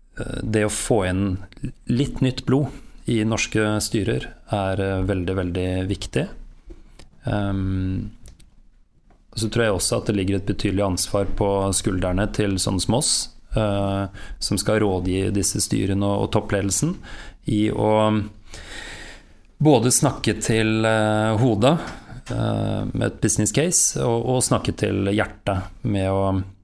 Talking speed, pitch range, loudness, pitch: 120 wpm, 95-115 Hz, -22 LUFS, 105 Hz